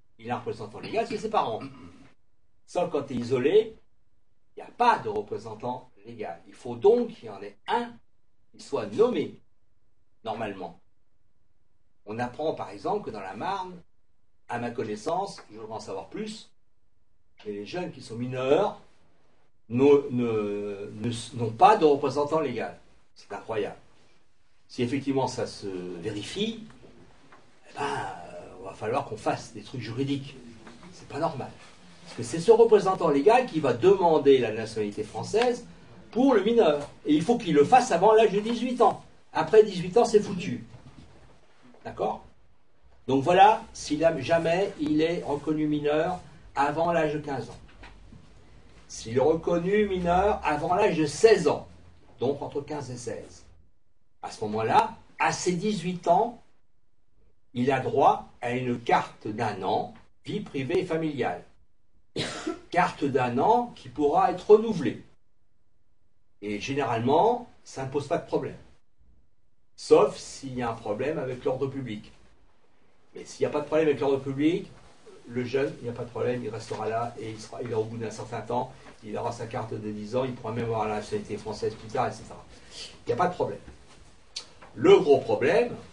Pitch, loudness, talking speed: 135 Hz, -26 LUFS, 170 wpm